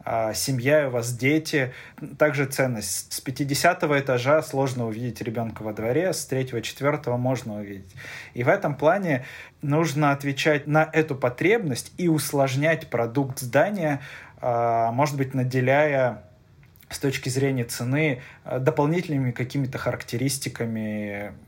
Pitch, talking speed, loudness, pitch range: 135 Hz, 115 wpm, -24 LUFS, 120-145 Hz